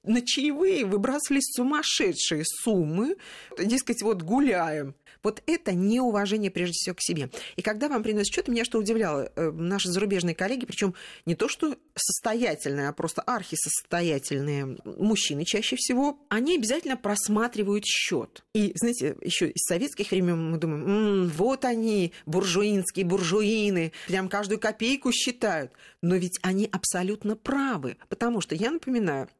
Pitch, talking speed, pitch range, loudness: 210 Hz, 135 wpm, 180-240 Hz, -26 LUFS